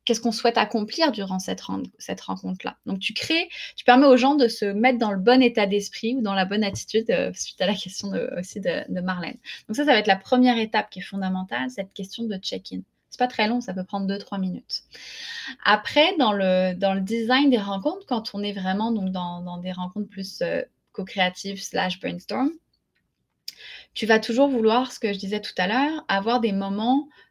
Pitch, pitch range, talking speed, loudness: 210 Hz, 190-245 Hz, 220 wpm, -23 LUFS